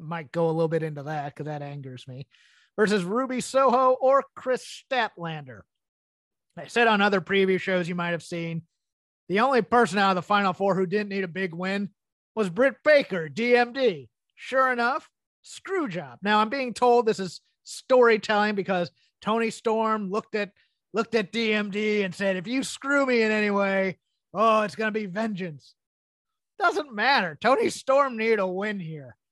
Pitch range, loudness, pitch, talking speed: 175-235 Hz, -25 LUFS, 205 Hz, 180 wpm